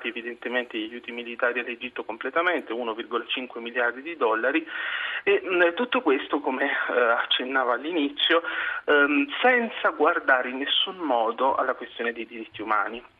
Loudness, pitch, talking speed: -25 LUFS, 165 Hz, 120 wpm